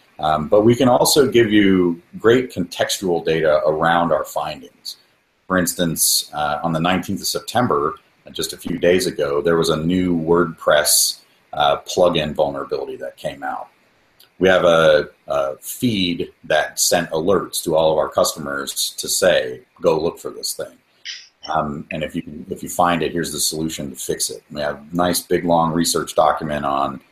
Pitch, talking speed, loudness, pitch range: 85 Hz, 175 wpm, -18 LUFS, 75-90 Hz